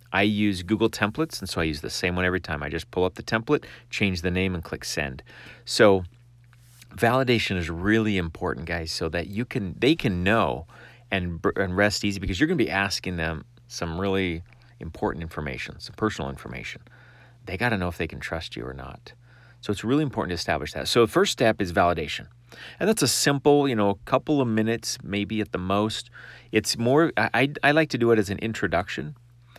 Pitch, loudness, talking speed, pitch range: 105 Hz, -25 LUFS, 215 wpm, 90-120 Hz